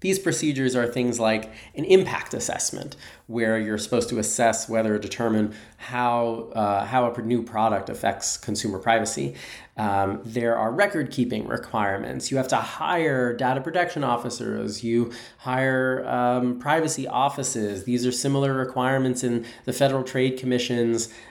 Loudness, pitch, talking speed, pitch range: -24 LUFS, 120 Hz, 145 wpm, 110-130 Hz